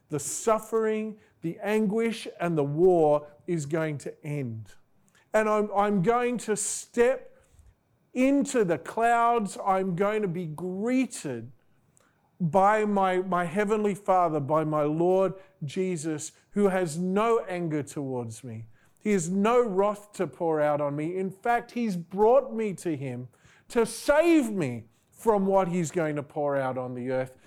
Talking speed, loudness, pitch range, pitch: 150 wpm, -27 LUFS, 150-215 Hz, 185 Hz